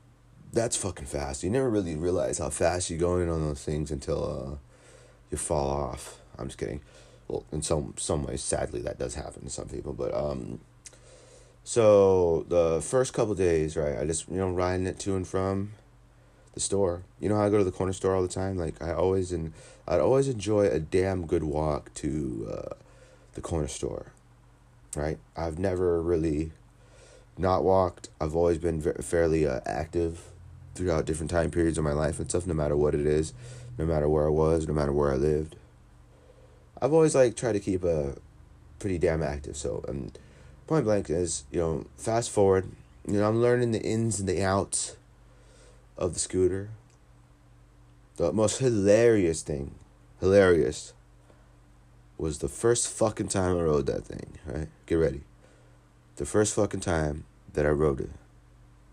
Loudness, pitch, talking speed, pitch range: -28 LUFS, 85 Hz, 180 wpm, 75-100 Hz